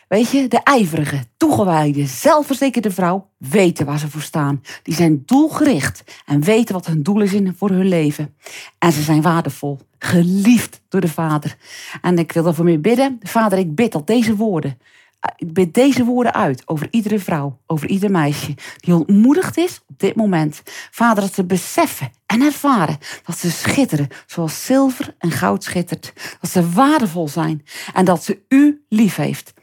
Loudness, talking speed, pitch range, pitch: -17 LUFS, 170 wpm, 155-225 Hz, 180 Hz